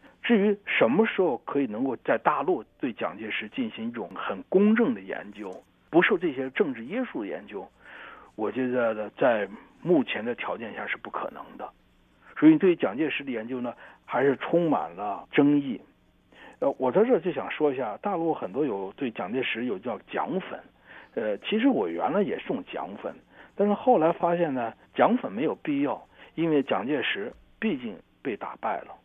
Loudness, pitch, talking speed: -27 LUFS, 215 Hz, 260 characters per minute